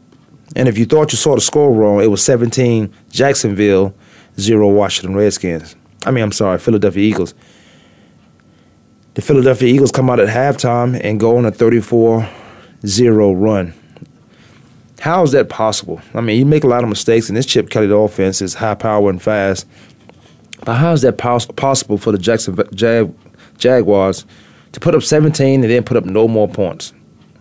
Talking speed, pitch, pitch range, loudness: 175 wpm, 110 Hz, 100-125 Hz, -13 LUFS